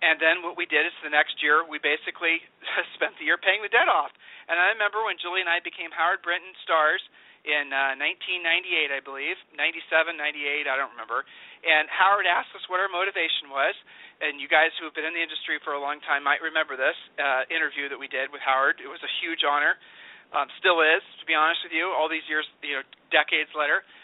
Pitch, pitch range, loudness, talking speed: 160 Hz, 150-175 Hz, -24 LUFS, 225 wpm